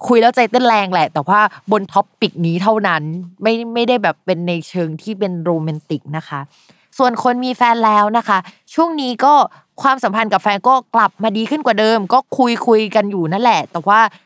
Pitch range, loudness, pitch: 180-235 Hz, -15 LUFS, 215 Hz